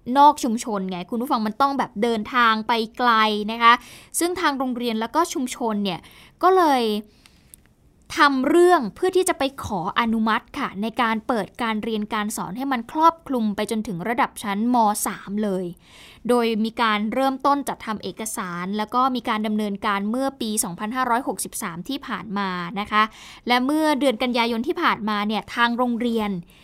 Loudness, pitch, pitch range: -22 LUFS, 230 Hz, 215-260 Hz